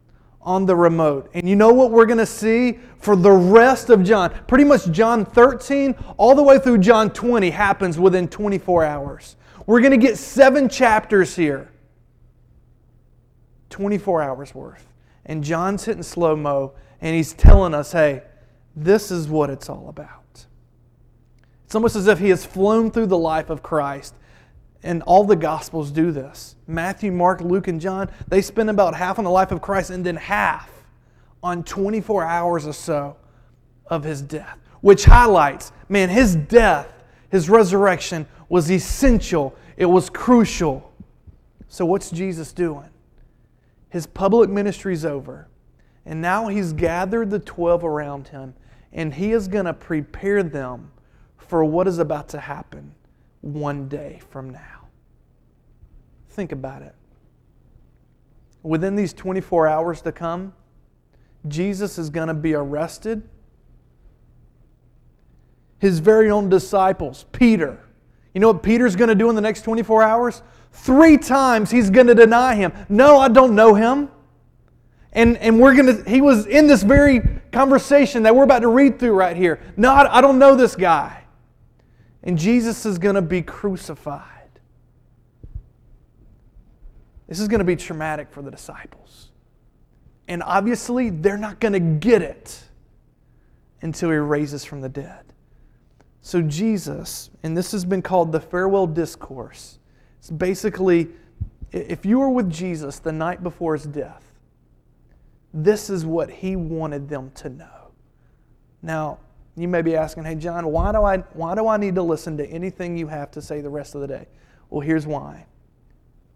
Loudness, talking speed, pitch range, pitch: -17 LUFS, 155 wpm, 150-210 Hz, 175 Hz